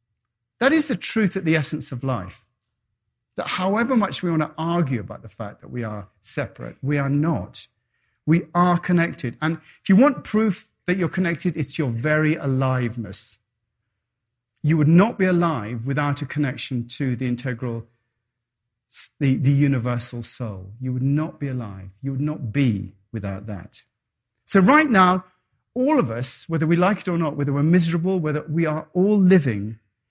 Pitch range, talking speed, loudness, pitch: 115-170 Hz, 175 wpm, -22 LUFS, 140 Hz